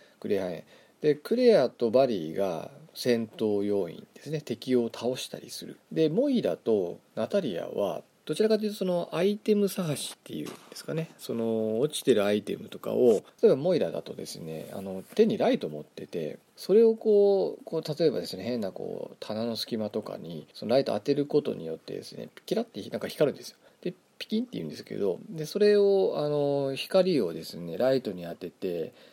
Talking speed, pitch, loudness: 340 characters per minute, 145 Hz, -28 LUFS